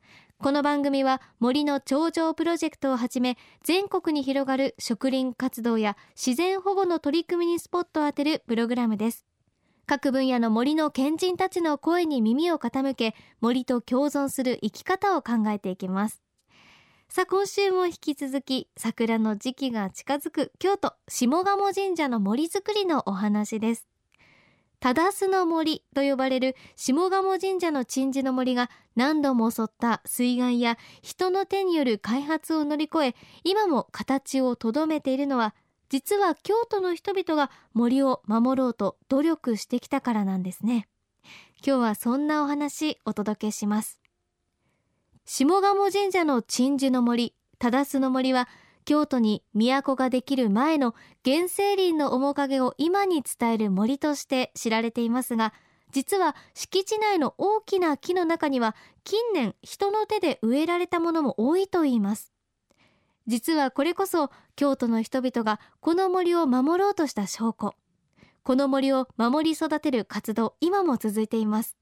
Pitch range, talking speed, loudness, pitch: 235-330 Hz, 285 characters per minute, -26 LUFS, 275 Hz